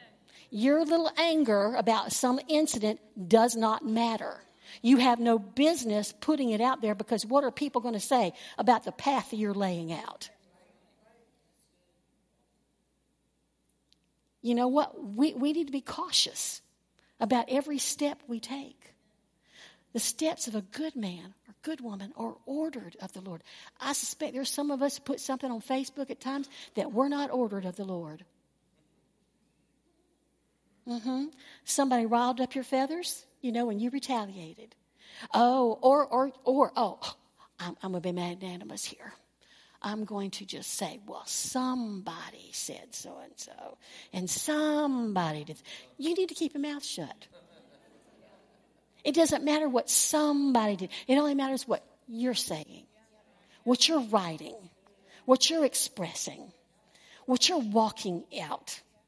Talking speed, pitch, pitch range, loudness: 145 wpm, 250 Hz, 215-280 Hz, -29 LUFS